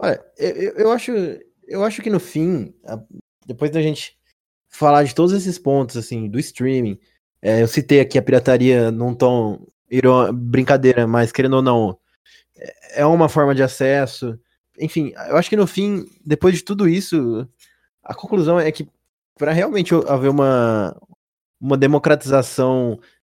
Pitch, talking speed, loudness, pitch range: 140 Hz, 150 wpm, -17 LUFS, 125-165 Hz